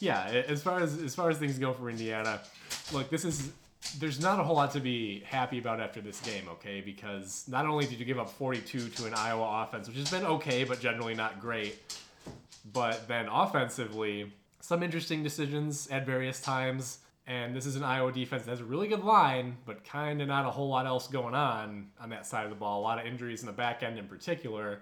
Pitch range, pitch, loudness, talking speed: 115-145 Hz, 125 Hz, -33 LUFS, 225 wpm